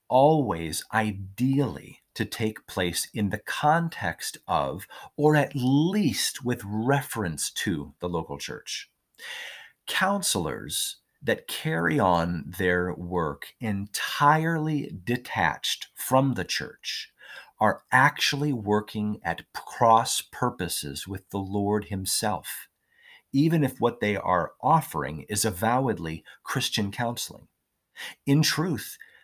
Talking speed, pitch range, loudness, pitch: 105 wpm, 95-145 Hz, -26 LUFS, 110 Hz